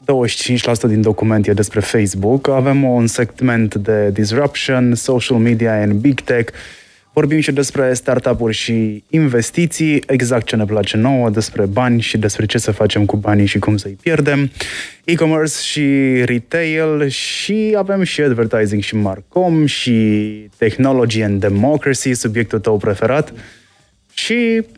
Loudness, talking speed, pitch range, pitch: -15 LUFS, 140 wpm, 110-140 Hz, 120 Hz